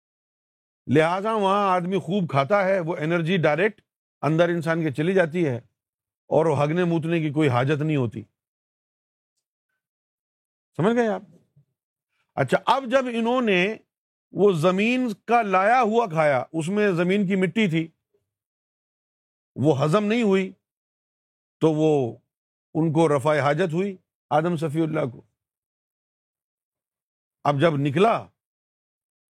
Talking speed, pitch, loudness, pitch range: 125 wpm, 175 Hz, -22 LUFS, 150-200 Hz